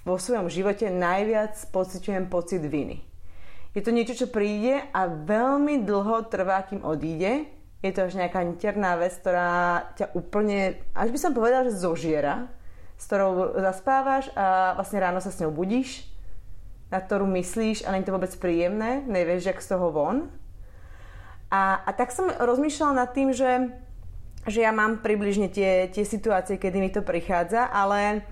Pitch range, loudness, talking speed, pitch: 175-220 Hz, -25 LUFS, 165 wpm, 195 Hz